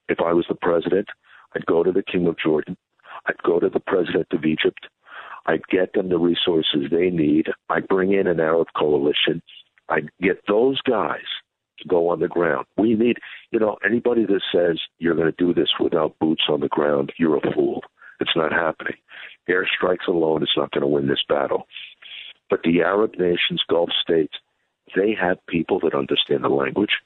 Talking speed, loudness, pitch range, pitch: 190 wpm, -21 LUFS, 80-100 Hz, 85 Hz